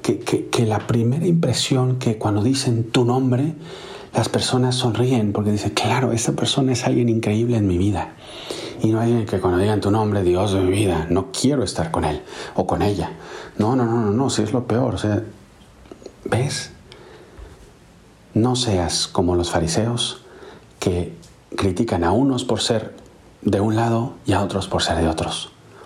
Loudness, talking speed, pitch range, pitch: -20 LUFS, 180 wpm, 100-125 Hz, 110 Hz